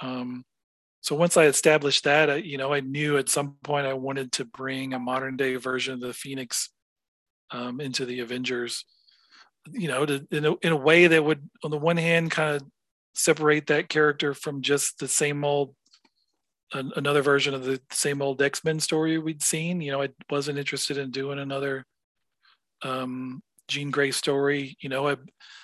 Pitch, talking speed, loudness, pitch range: 140 Hz, 185 wpm, -25 LUFS, 135-150 Hz